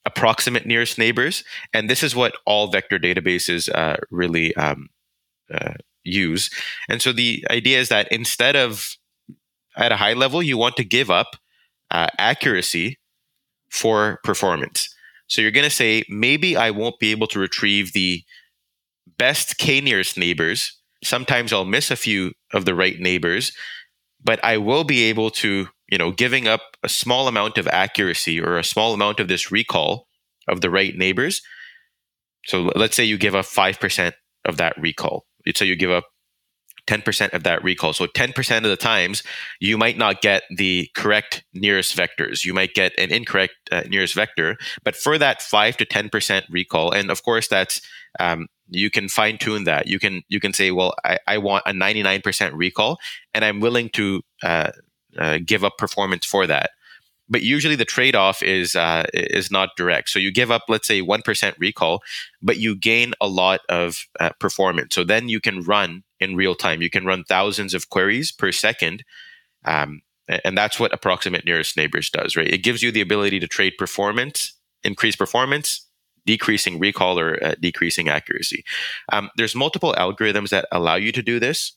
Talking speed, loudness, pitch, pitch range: 185 wpm, -19 LUFS, 100 Hz, 90-110 Hz